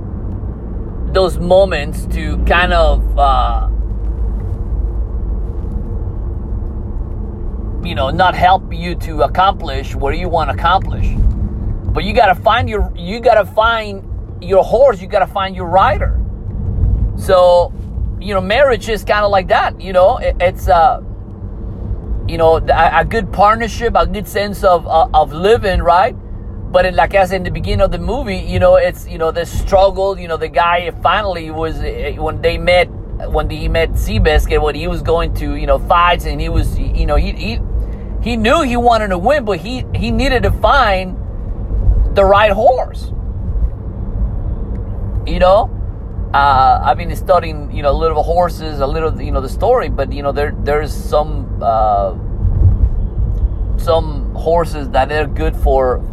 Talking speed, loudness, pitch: 170 wpm, -15 LUFS, 100 Hz